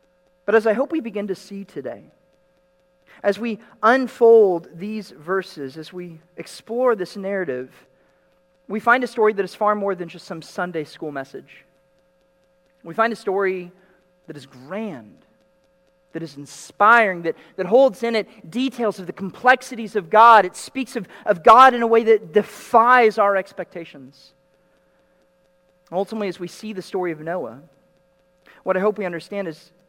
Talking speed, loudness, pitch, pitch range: 160 wpm, -19 LUFS, 185 Hz, 180-215 Hz